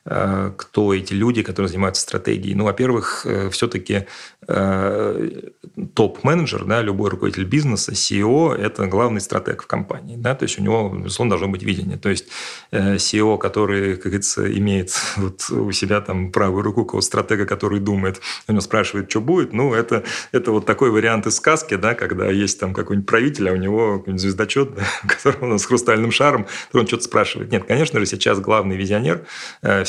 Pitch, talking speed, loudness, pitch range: 100 Hz, 175 wpm, -19 LUFS, 95-110 Hz